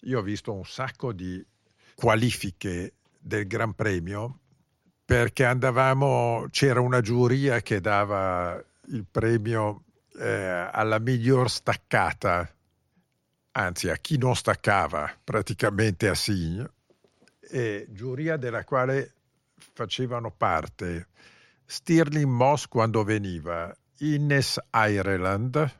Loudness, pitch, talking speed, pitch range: -26 LUFS, 115 Hz, 100 wpm, 100-130 Hz